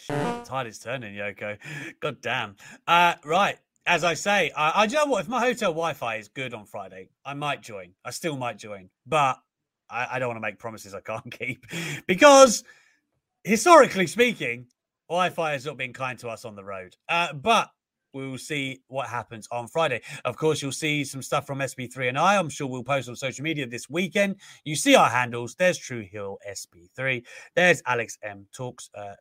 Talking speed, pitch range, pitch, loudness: 200 wpm, 120-170 Hz, 135 Hz, -24 LUFS